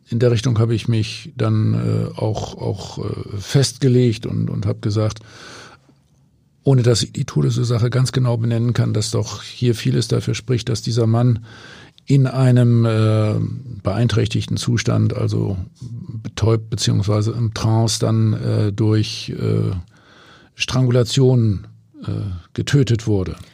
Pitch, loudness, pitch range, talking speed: 115 Hz, -19 LUFS, 110-125 Hz, 135 wpm